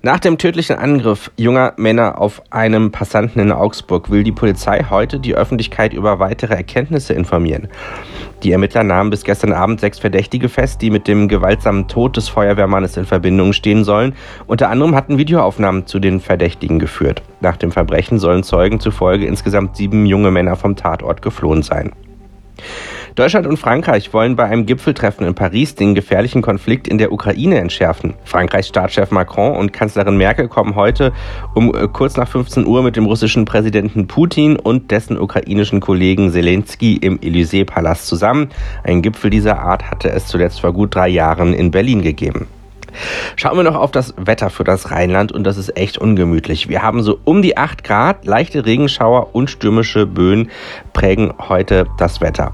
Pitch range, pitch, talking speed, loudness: 95-115 Hz, 105 Hz, 170 wpm, -14 LUFS